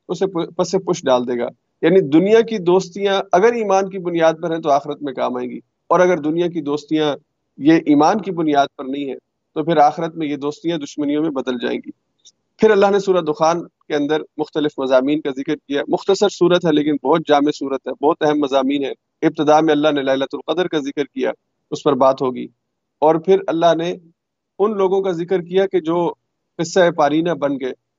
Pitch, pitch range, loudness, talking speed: 155 Hz, 145-180 Hz, -18 LUFS, 210 wpm